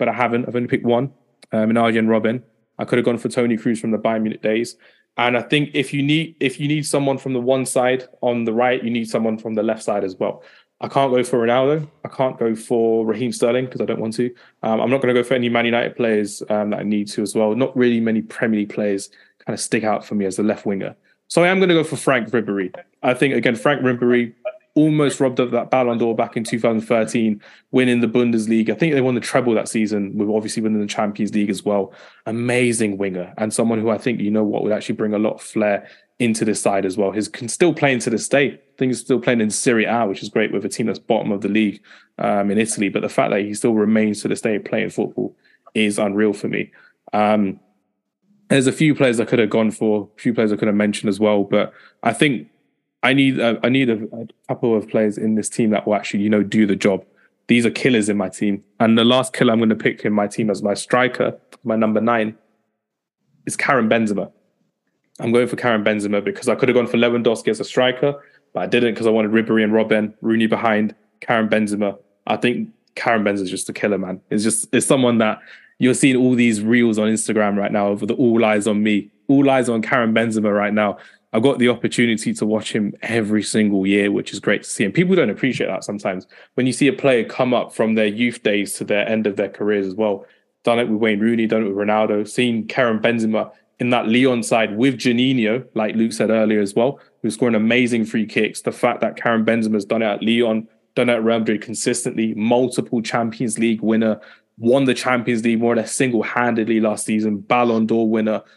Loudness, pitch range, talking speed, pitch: -19 LUFS, 105-125 Hz, 245 wpm, 115 Hz